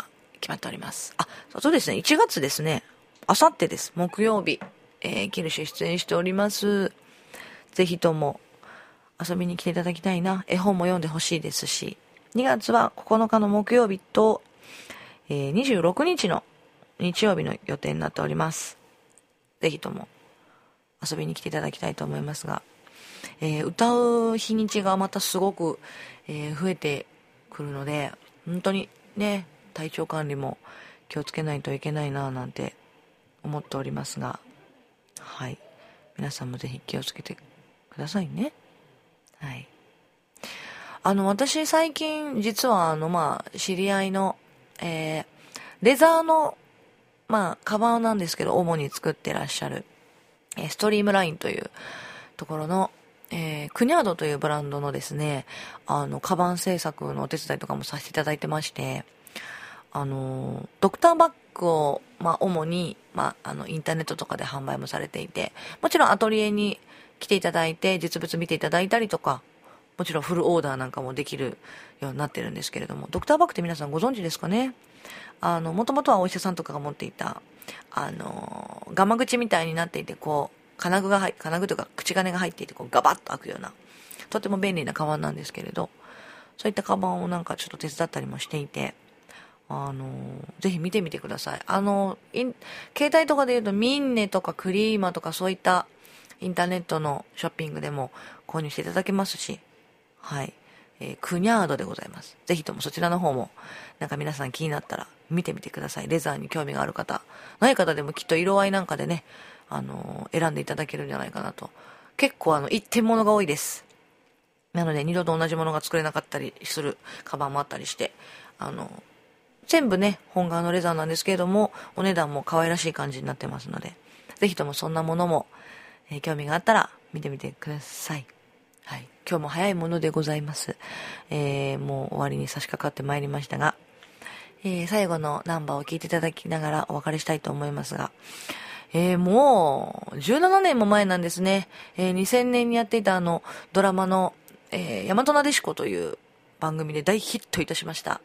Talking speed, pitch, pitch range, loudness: 360 characters per minute, 175 Hz, 150-205 Hz, -26 LUFS